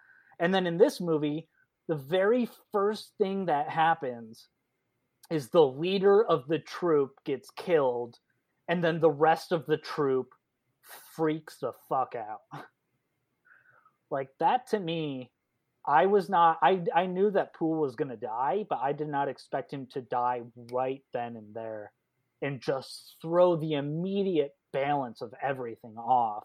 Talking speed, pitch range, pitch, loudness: 150 wpm, 130-175 Hz, 155 Hz, -29 LUFS